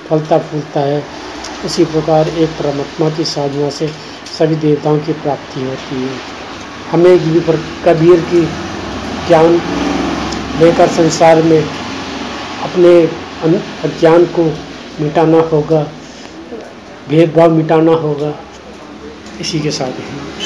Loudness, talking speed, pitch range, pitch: -13 LUFS, 105 wpm, 150-165 Hz, 160 Hz